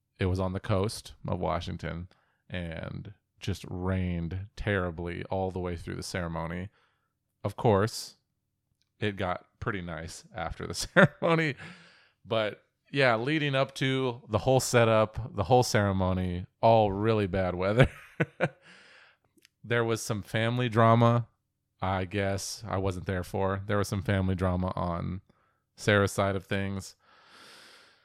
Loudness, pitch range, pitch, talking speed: -29 LUFS, 95-115 Hz, 100 Hz, 135 wpm